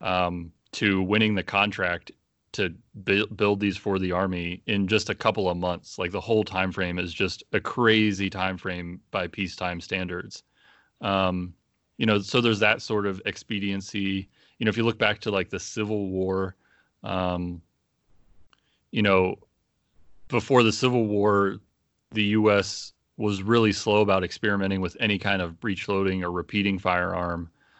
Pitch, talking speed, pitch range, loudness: 100 Hz, 160 wpm, 90-105 Hz, -25 LUFS